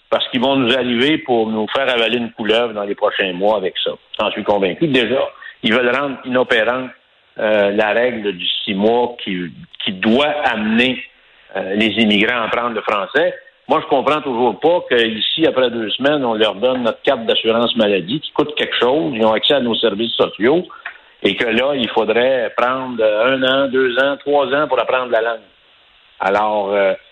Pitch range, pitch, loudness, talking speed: 110-130 Hz, 115 Hz, -16 LUFS, 195 wpm